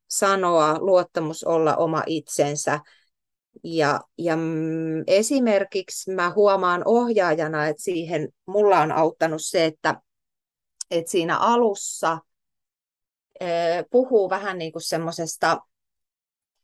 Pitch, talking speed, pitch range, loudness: 170 Hz, 95 wpm, 160-195 Hz, -22 LUFS